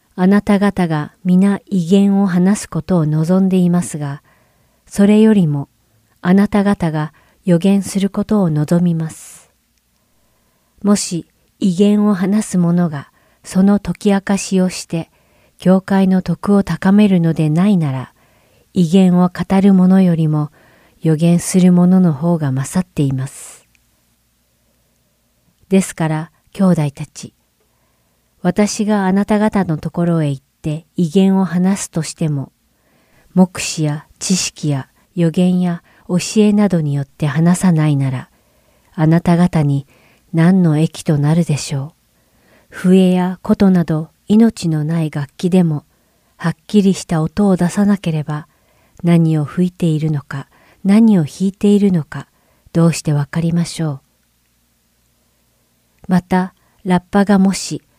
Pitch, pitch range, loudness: 175 Hz, 150-190 Hz, -15 LUFS